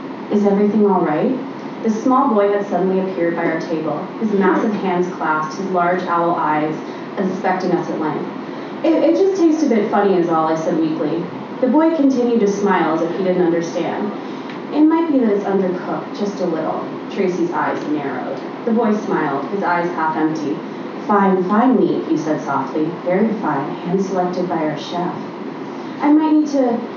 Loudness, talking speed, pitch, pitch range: -18 LUFS, 185 wpm, 190 Hz, 170-245 Hz